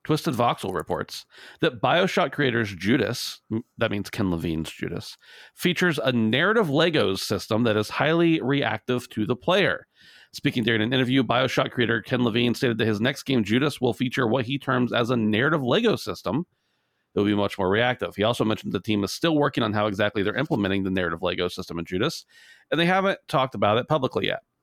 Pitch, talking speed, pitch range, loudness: 120 Hz, 195 wpm, 105-140 Hz, -24 LUFS